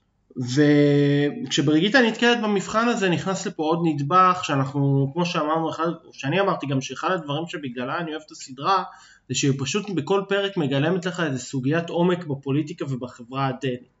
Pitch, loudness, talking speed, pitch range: 155 Hz, -23 LUFS, 145 wpm, 140-185 Hz